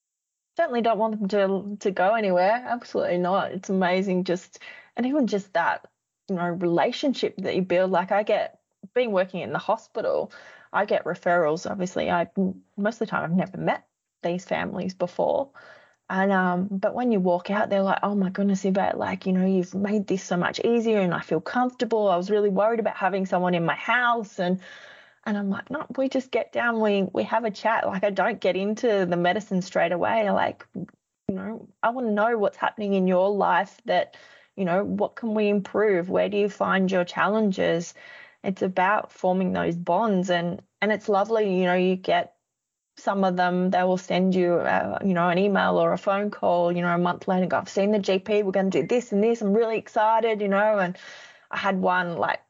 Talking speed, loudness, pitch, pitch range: 215 wpm, -24 LUFS, 200 Hz, 185-220 Hz